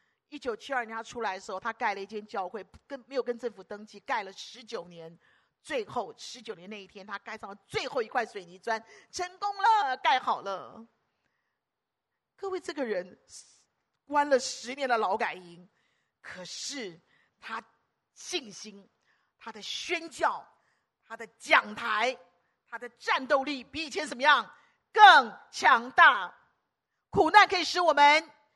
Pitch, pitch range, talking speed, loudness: 245 Hz, 210-300 Hz, 215 characters per minute, -27 LUFS